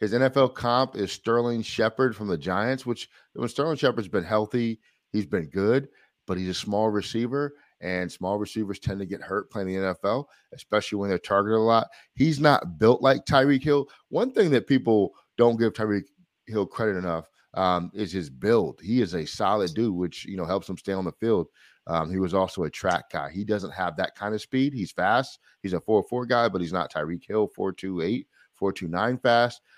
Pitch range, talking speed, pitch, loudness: 95-120 Hz, 205 wpm, 105 Hz, -26 LUFS